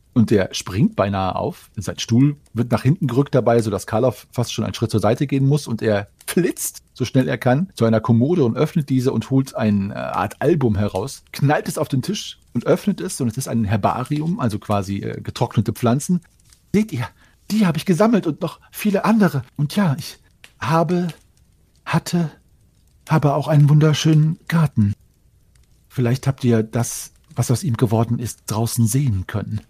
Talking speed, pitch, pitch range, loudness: 185 wpm, 125 Hz, 110-150 Hz, -20 LUFS